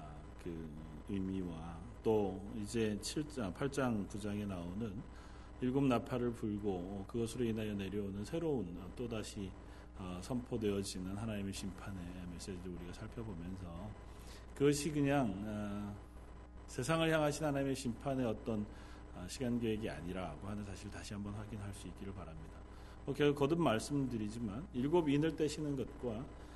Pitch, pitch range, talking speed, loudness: 105 Hz, 95-125 Hz, 295 characters per minute, -39 LUFS